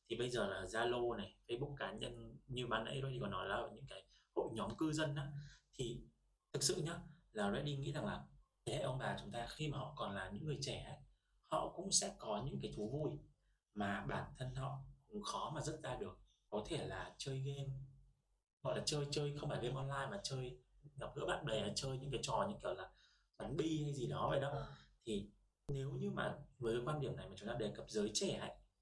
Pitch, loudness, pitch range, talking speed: 135 Hz, -43 LUFS, 110-145 Hz, 240 wpm